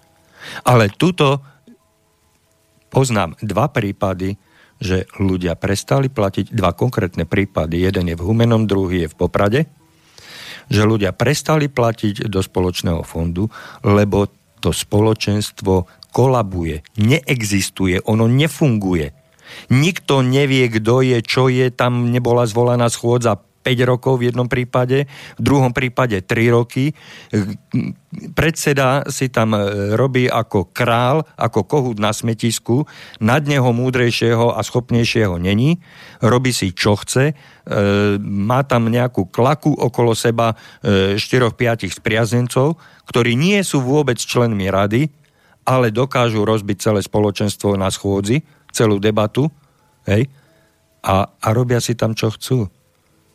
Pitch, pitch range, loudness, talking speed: 115 Hz, 100-130 Hz, -17 LUFS, 120 wpm